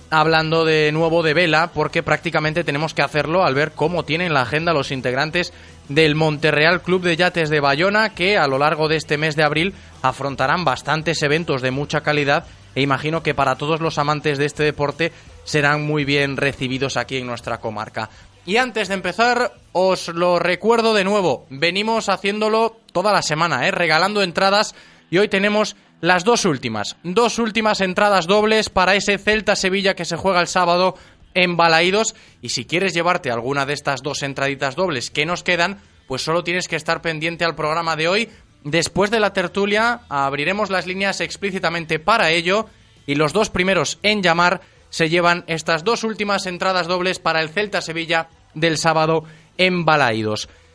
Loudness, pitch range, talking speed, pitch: -18 LUFS, 150-190 Hz, 175 wpm, 165 Hz